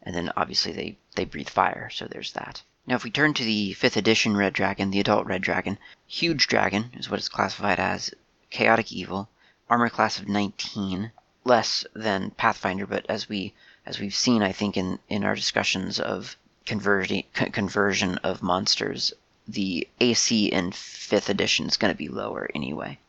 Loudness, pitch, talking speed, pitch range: -25 LUFS, 105 Hz, 180 wpm, 100-115 Hz